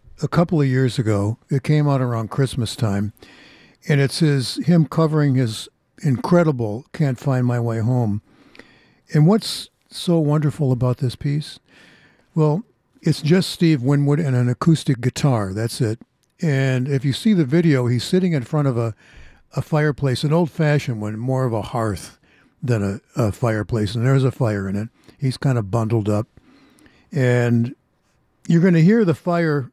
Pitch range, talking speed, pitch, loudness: 115-155 Hz, 170 wpm, 135 Hz, -20 LUFS